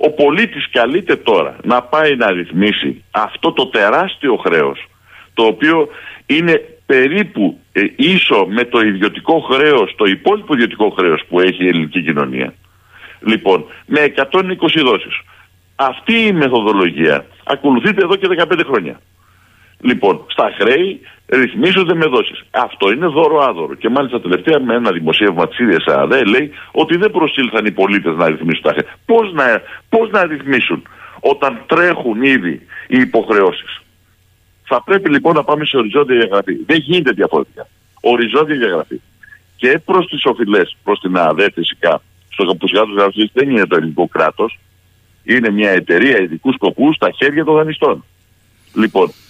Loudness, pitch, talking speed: -13 LUFS, 135 Hz, 150 wpm